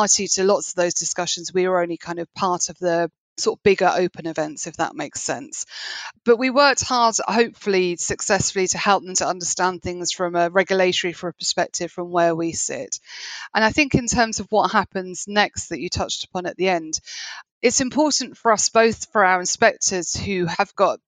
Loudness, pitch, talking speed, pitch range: -21 LUFS, 185 Hz, 200 wpm, 175-210 Hz